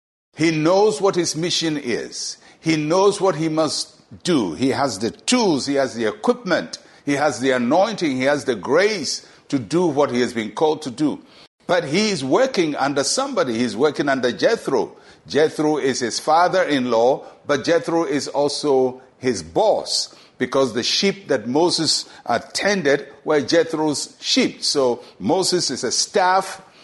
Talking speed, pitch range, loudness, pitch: 160 wpm, 130-180 Hz, -20 LUFS, 155 Hz